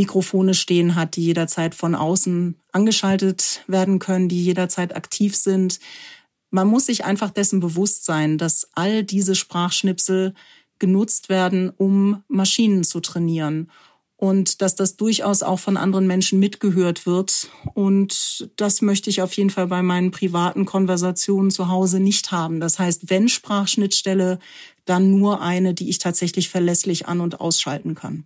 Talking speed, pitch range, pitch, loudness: 150 wpm, 175-195 Hz, 190 Hz, -19 LUFS